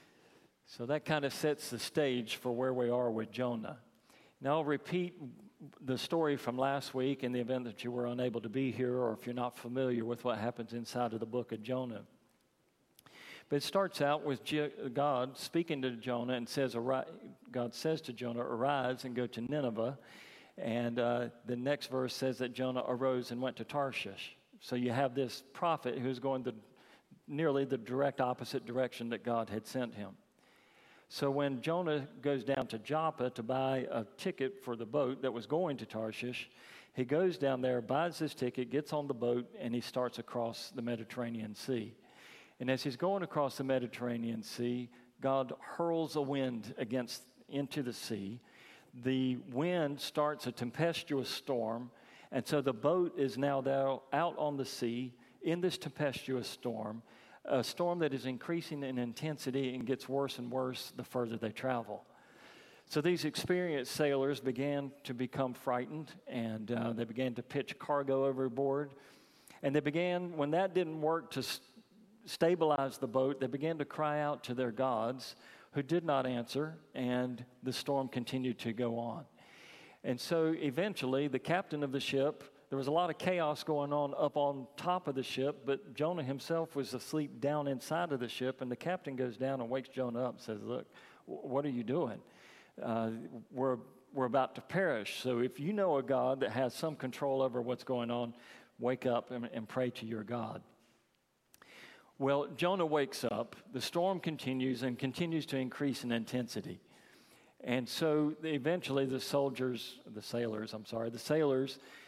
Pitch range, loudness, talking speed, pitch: 120-145 Hz, -36 LUFS, 180 wpm, 130 Hz